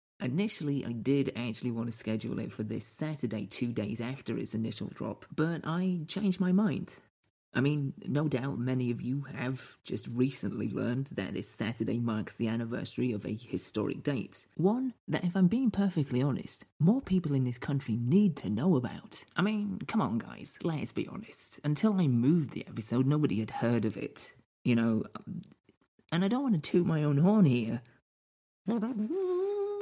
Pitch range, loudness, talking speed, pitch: 115-175 Hz, -31 LUFS, 180 wpm, 135 Hz